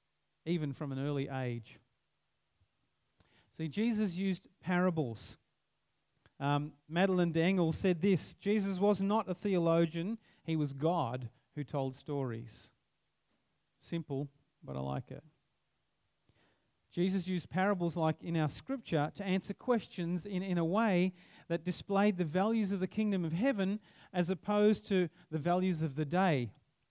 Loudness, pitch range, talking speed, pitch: -34 LUFS, 145-190 Hz, 135 wpm, 170 Hz